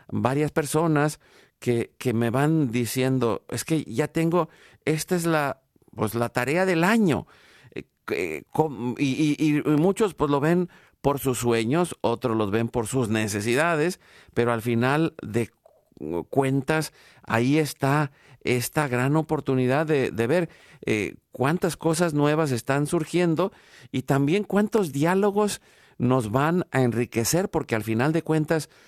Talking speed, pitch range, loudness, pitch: 145 wpm, 125-160 Hz, -24 LUFS, 145 Hz